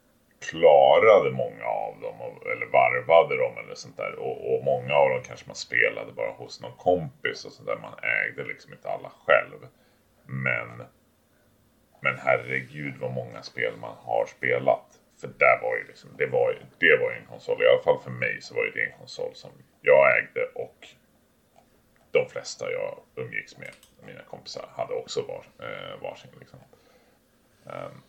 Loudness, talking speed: -25 LUFS, 170 wpm